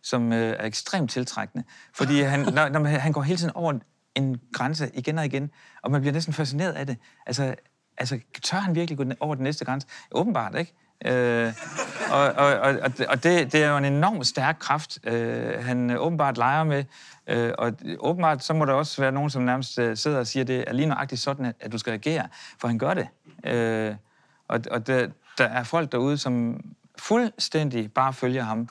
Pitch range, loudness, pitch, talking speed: 125-155 Hz, -25 LUFS, 135 Hz, 205 wpm